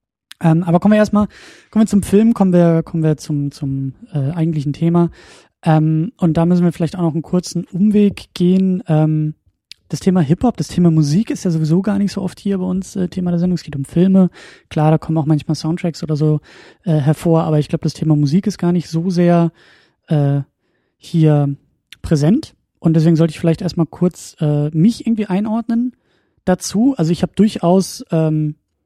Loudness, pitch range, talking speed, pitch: -16 LUFS, 155-190 Hz, 205 wpm, 170 Hz